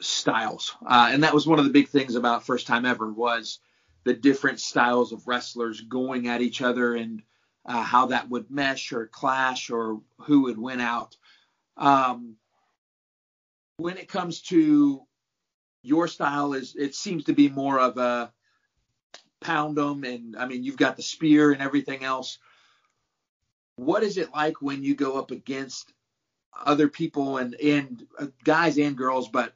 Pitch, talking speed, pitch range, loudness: 135 Hz, 165 wpm, 120-145 Hz, -24 LUFS